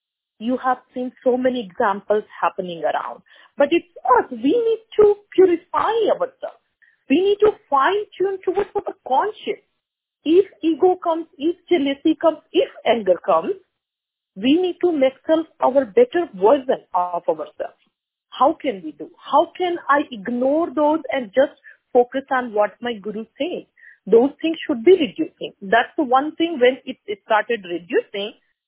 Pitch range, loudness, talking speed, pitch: 245-355 Hz, -20 LUFS, 155 wpm, 290 Hz